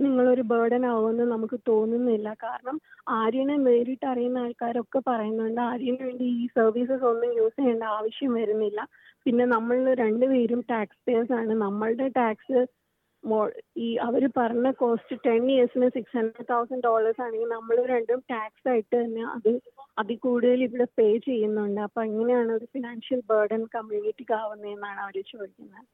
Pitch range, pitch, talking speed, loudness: 225-250 Hz, 235 Hz, 140 wpm, -26 LUFS